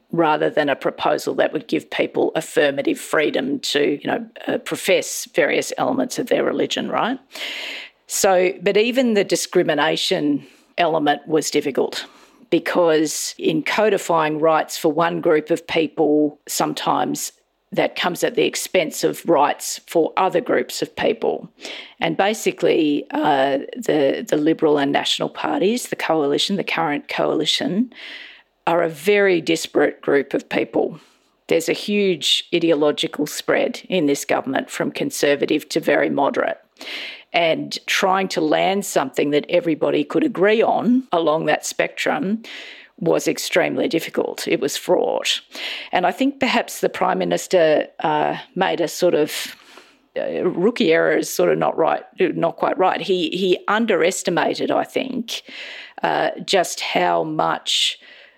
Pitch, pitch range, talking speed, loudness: 180 Hz, 155-250 Hz, 140 wpm, -20 LUFS